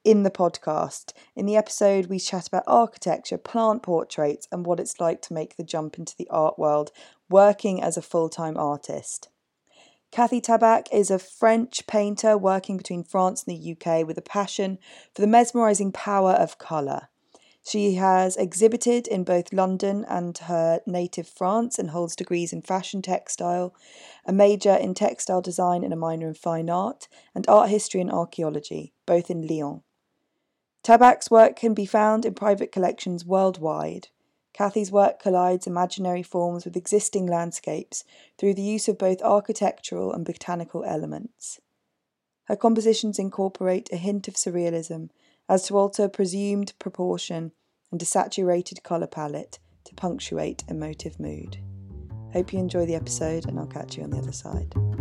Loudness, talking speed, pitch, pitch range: -24 LUFS, 160 wpm, 185 Hz, 170-205 Hz